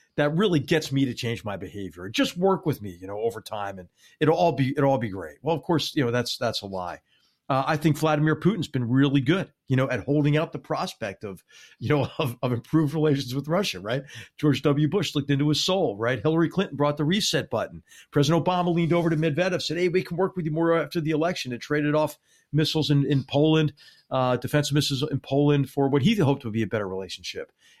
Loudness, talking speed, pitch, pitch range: -25 LUFS, 235 wpm, 150 Hz, 130-165 Hz